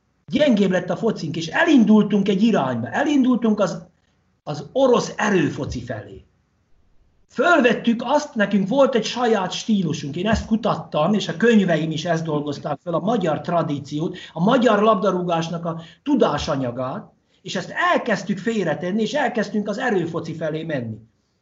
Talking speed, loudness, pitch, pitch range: 135 wpm, -20 LUFS, 185 Hz, 155-225 Hz